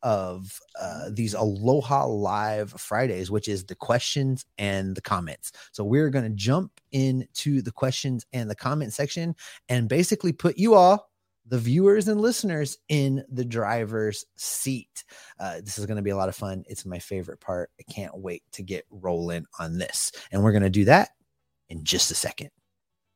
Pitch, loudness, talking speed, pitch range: 115 Hz, -25 LUFS, 175 wpm, 100-135 Hz